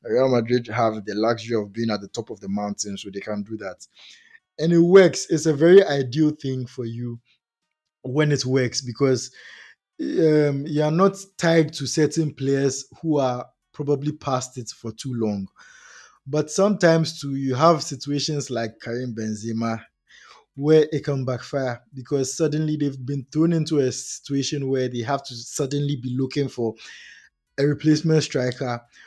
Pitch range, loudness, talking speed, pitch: 120-155 Hz, -22 LUFS, 165 wpm, 140 Hz